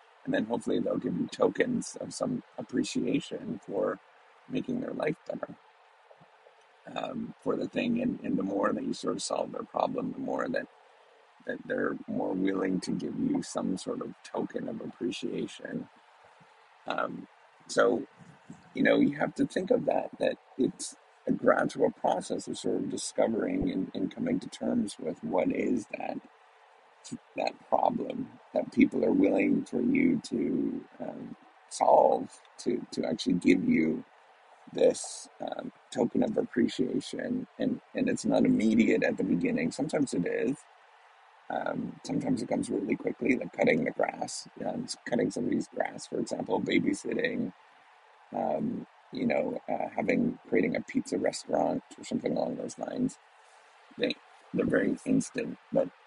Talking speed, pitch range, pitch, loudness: 155 wpm, 250-280 Hz, 260 Hz, -31 LUFS